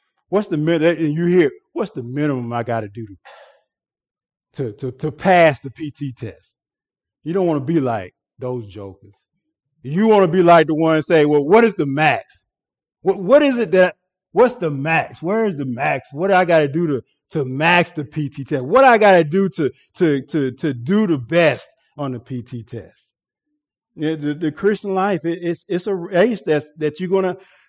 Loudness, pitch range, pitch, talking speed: -18 LUFS, 135-185 Hz, 160 Hz, 205 wpm